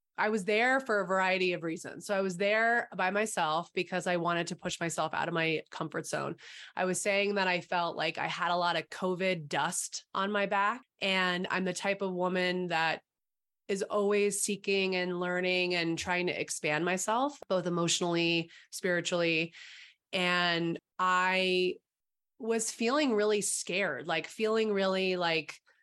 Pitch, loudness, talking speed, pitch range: 185 Hz, -31 LUFS, 165 wpm, 175-200 Hz